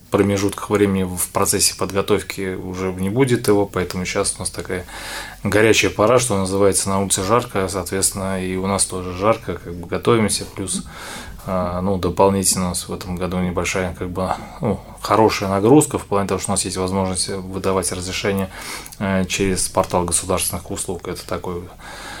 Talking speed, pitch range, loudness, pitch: 160 wpm, 90-100 Hz, -19 LUFS, 95 Hz